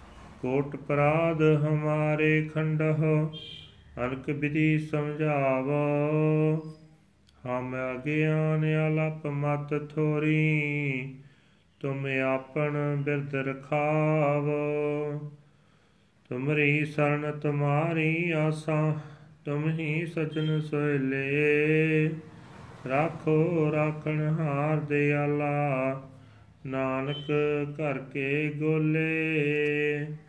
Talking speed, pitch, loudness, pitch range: 65 wpm, 150 Hz, -27 LUFS, 145-155 Hz